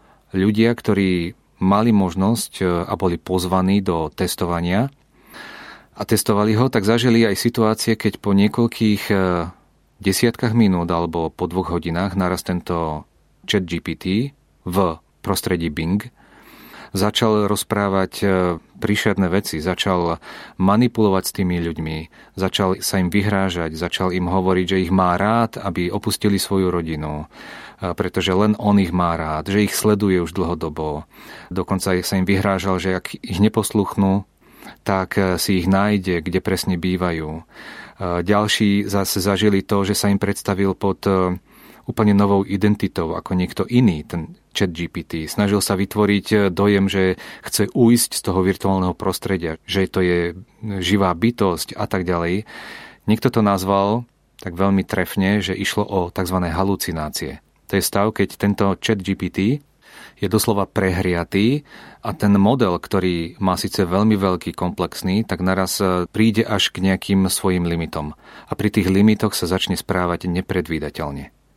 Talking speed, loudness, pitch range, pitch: 140 wpm, -20 LUFS, 90-105 Hz, 95 Hz